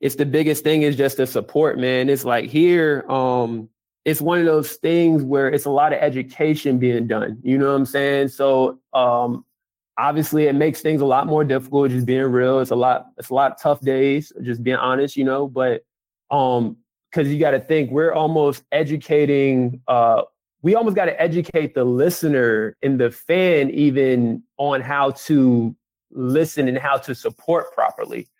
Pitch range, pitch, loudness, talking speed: 130-150 Hz, 140 Hz, -19 LUFS, 185 wpm